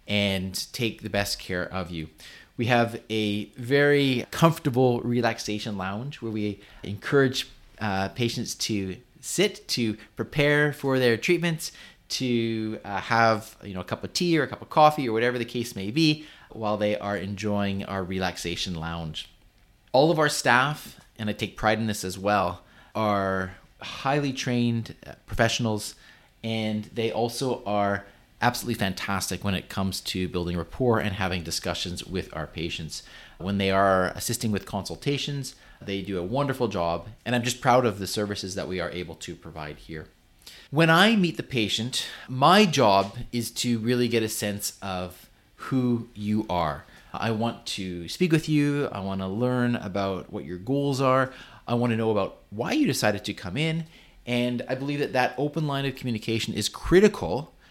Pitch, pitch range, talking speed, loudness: 110 Hz, 95-125 Hz, 175 wpm, -26 LUFS